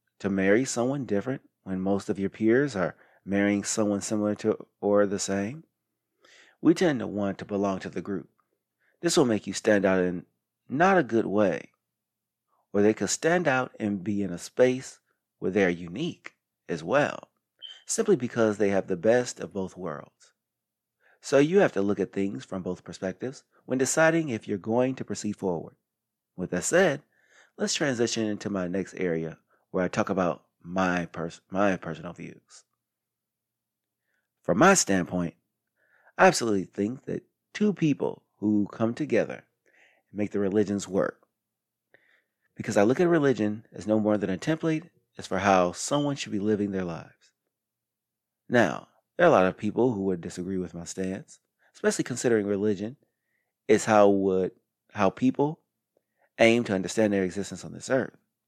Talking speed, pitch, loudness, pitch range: 170 wpm, 105 Hz, -26 LUFS, 95-115 Hz